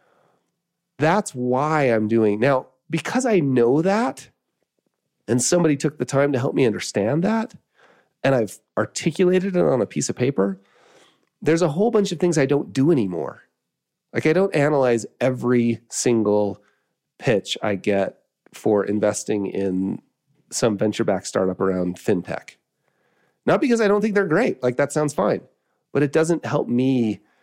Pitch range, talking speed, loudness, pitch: 105-160 Hz, 160 wpm, -21 LUFS, 130 Hz